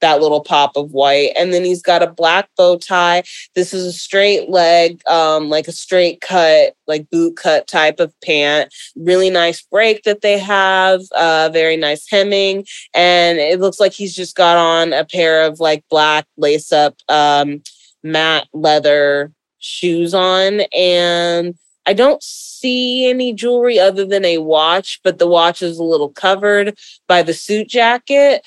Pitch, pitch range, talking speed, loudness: 175 Hz, 155-195 Hz, 170 wpm, -13 LUFS